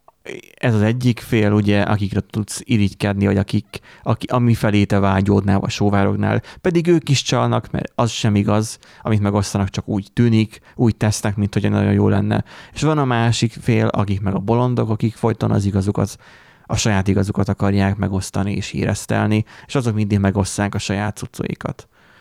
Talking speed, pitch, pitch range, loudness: 170 wpm, 105 Hz, 100-115 Hz, -19 LUFS